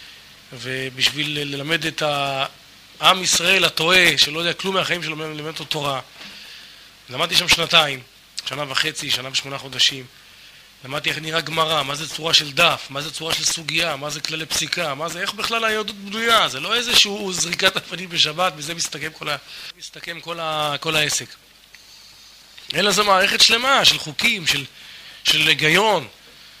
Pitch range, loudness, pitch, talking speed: 145-175 Hz, -18 LUFS, 160 Hz, 160 wpm